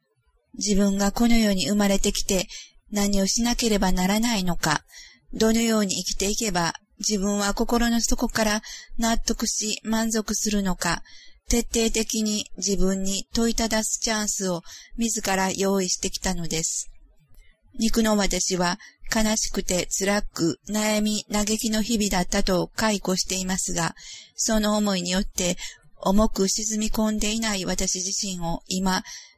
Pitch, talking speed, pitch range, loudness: 205 Hz, 275 characters per minute, 190-220 Hz, -24 LUFS